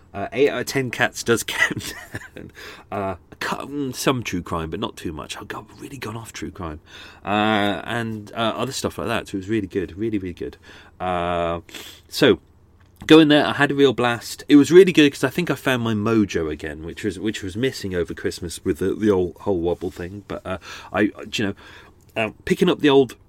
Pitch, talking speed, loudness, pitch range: 110 Hz, 215 wpm, -21 LUFS, 95-130 Hz